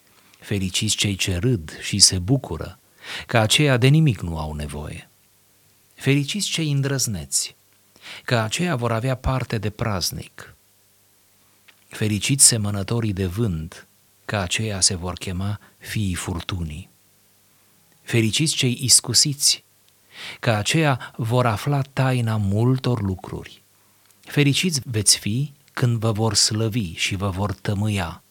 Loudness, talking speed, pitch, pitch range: -21 LUFS, 120 wpm, 105 Hz, 100-125 Hz